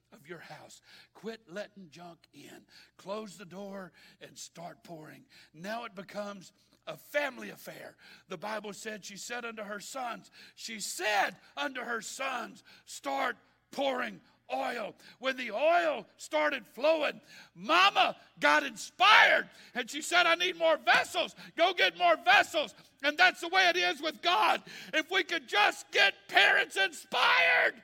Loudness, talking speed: -28 LUFS, 150 wpm